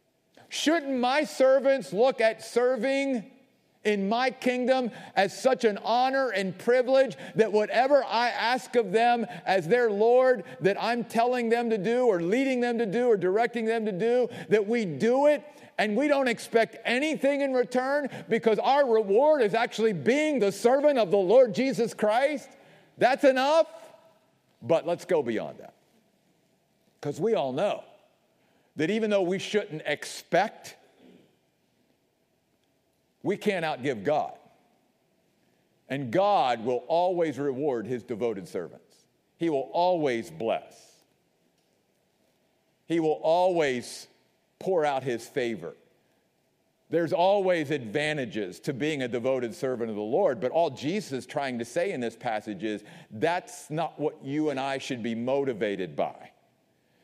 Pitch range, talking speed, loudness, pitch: 160-250 Hz, 145 wpm, -26 LUFS, 220 Hz